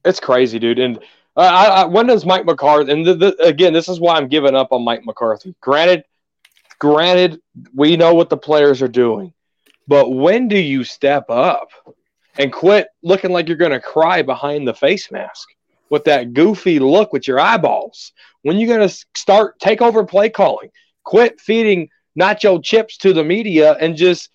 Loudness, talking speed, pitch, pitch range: -14 LUFS, 190 wpm, 170 Hz, 145-195 Hz